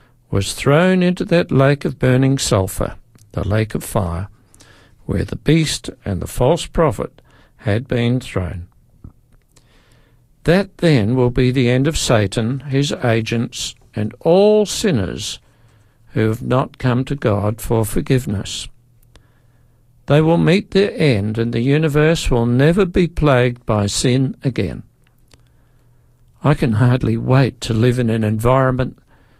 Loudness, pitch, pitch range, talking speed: -17 LUFS, 125 Hz, 115-135 Hz, 135 wpm